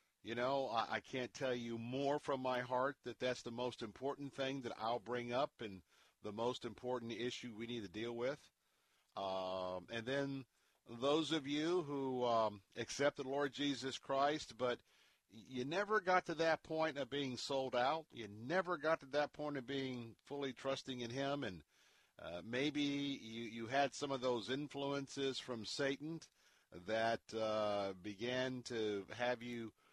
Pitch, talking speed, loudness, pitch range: 125 Hz, 170 wpm, -41 LUFS, 115-140 Hz